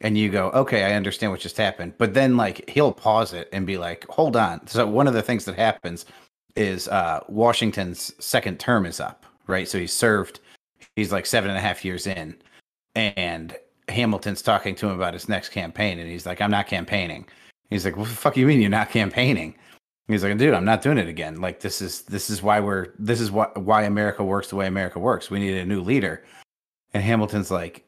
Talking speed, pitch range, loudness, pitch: 230 wpm, 95-110 Hz, -23 LUFS, 105 Hz